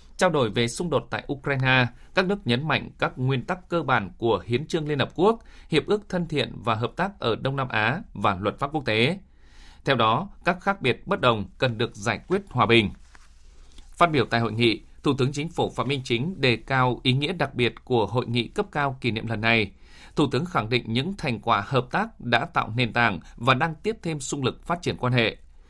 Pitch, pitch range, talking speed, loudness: 125 Hz, 115-150 Hz, 235 wpm, -25 LUFS